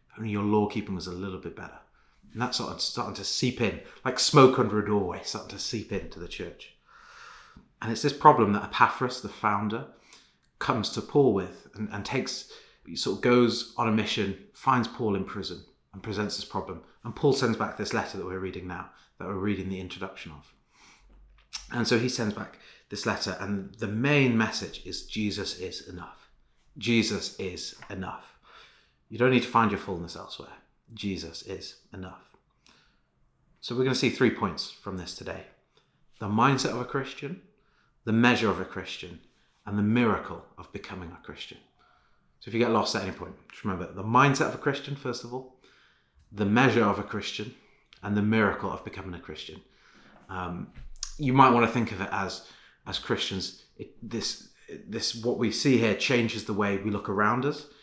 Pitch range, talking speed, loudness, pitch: 95-120 Hz, 190 wpm, -27 LUFS, 105 Hz